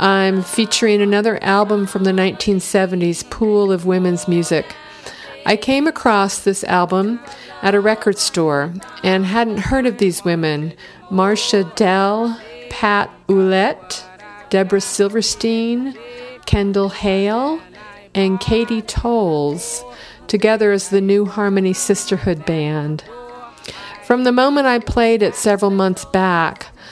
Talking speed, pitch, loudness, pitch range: 120 wpm, 200 Hz, -17 LUFS, 185-220 Hz